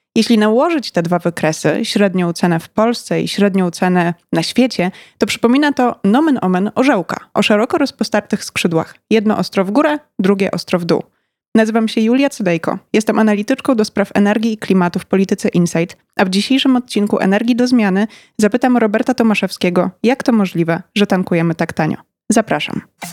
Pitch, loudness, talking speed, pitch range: 210 Hz, -15 LUFS, 165 wpm, 185-235 Hz